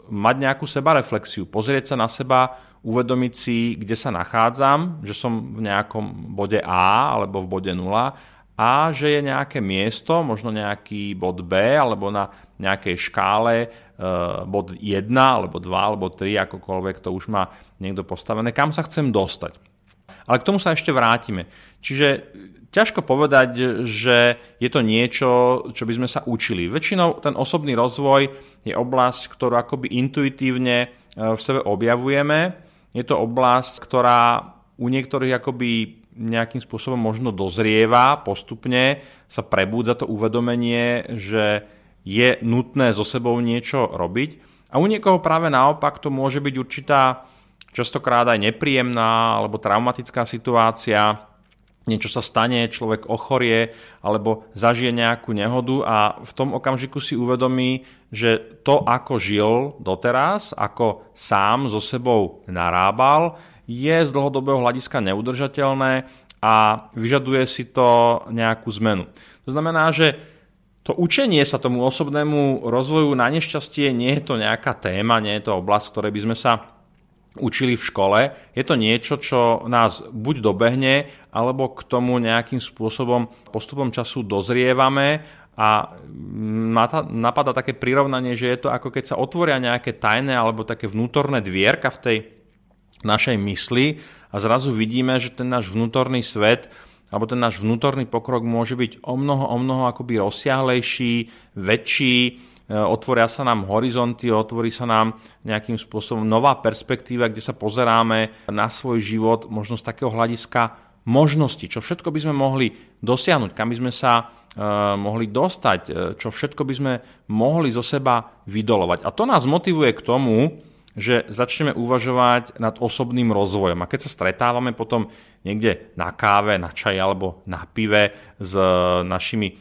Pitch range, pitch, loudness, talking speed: 110-130 Hz, 120 Hz, -20 LUFS, 145 wpm